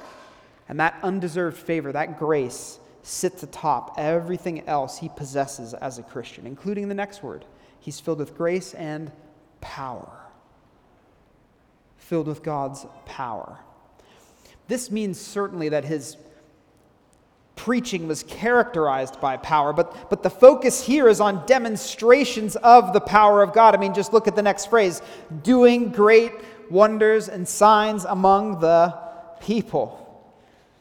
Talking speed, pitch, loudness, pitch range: 130 wpm, 185 Hz, -20 LUFS, 155-215 Hz